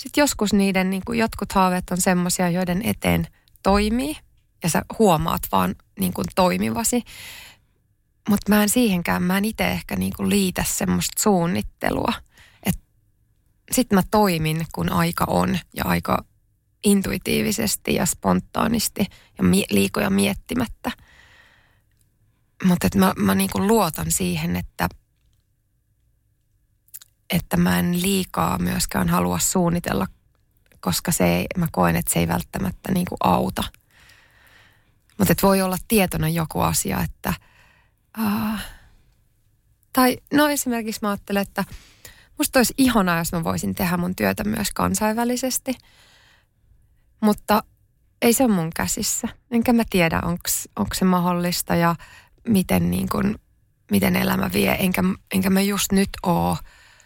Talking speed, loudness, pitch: 130 wpm, -21 LUFS, 180 Hz